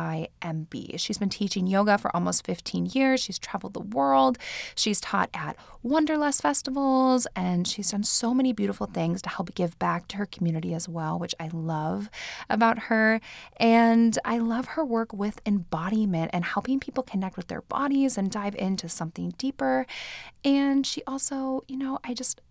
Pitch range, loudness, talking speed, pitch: 175-260 Hz, -26 LUFS, 175 wpm, 205 Hz